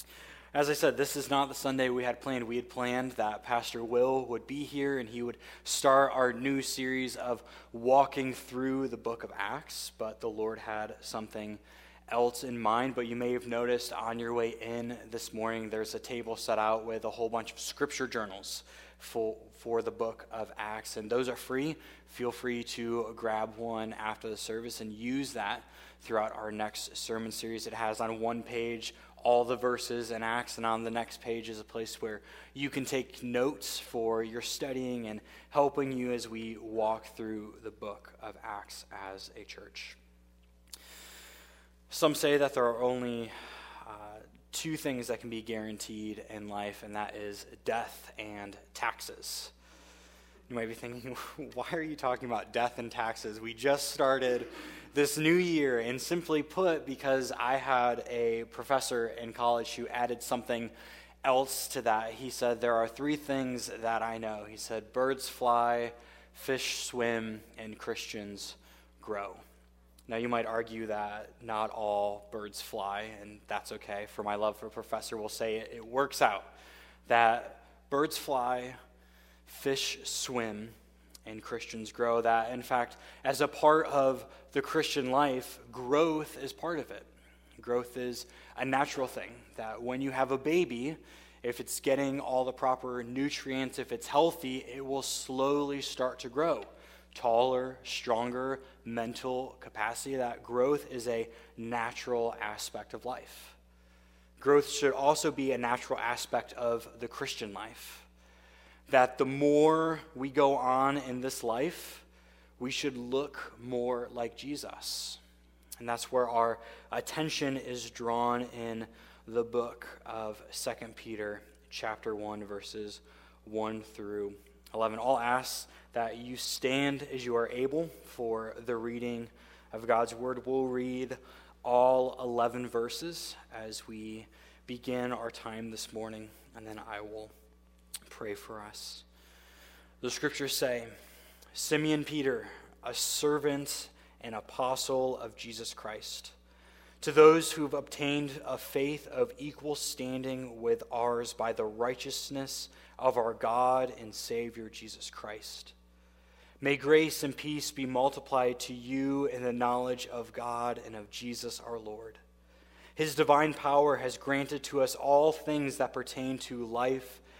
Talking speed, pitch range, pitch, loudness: 155 wpm, 110-130 Hz, 120 Hz, -33 LUFS